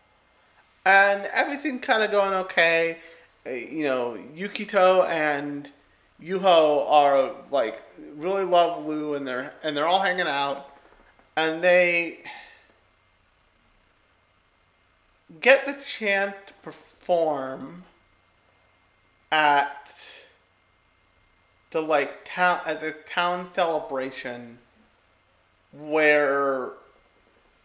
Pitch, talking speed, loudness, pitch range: 150 Hz, 85 wpm, -23 LUFS, 110-180 Hz